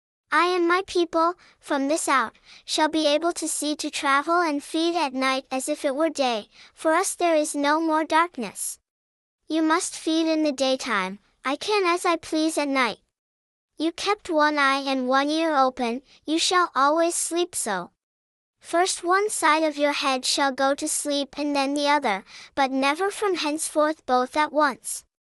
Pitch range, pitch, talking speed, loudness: 275-330 Hz, 300 Hz, 185 wpm, -23 LUFS